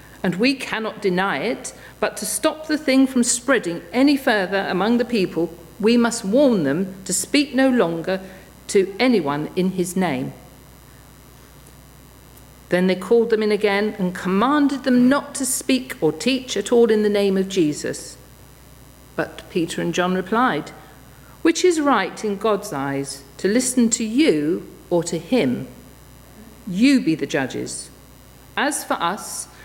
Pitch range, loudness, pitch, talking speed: 175-250 Hz, -20 LUFS, 200 Hz, 155 wpm